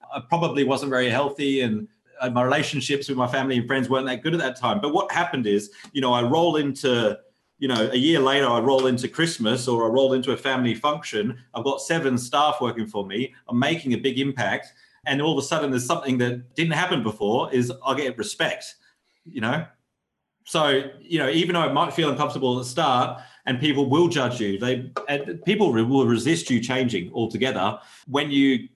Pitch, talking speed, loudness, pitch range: 135 Hz, 210 wpm, -23 LUFS, 125-145 Hz